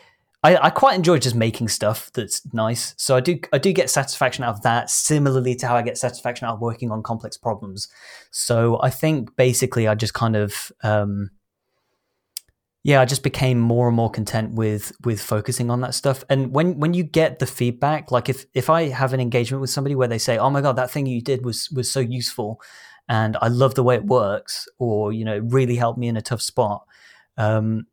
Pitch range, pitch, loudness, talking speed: 115-135 Hz, 125 Hz, -21 LUFS, 220 wpm